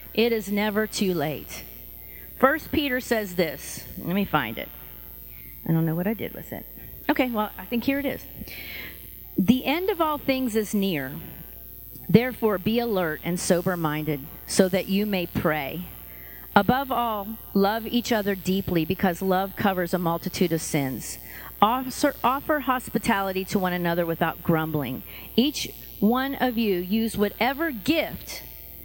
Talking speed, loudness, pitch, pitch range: 150 wpm, -25 LUFS, 195 Hz, 165-235 Hz